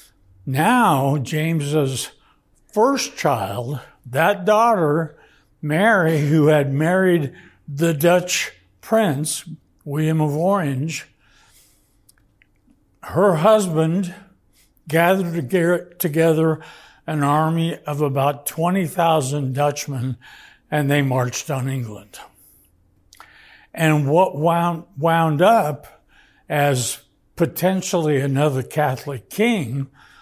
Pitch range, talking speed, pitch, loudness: 135-170 Hz, 80 wpm, 155 Hz, -19 LUFS